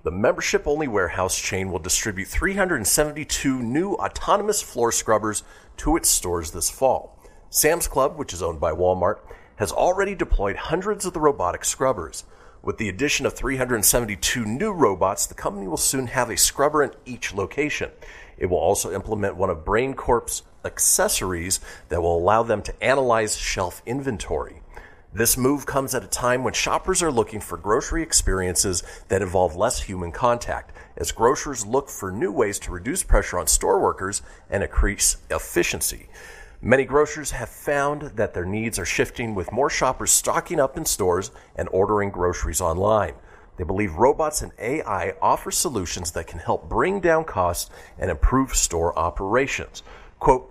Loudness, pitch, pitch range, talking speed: -22 LUFS, 115 Hz, 90-145 Hz, 160 wpm